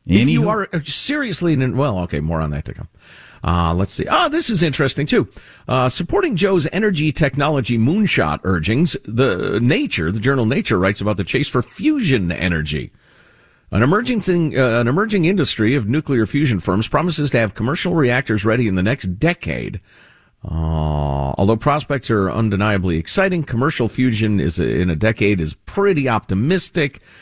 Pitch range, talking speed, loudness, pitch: 100-155 Hz, 165 wpm, -17 LUFS, 125 Hz